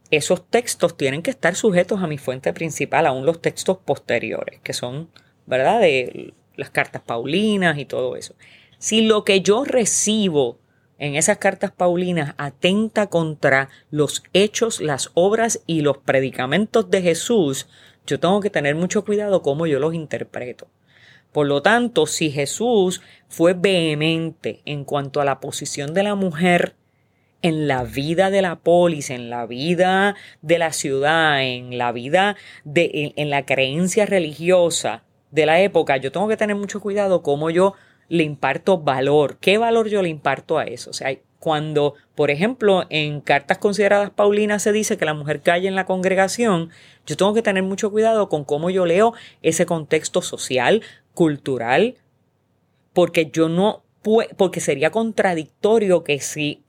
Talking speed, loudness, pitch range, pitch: 160 wpm, -19 LUFS, 145-200 Hz, 170 Hz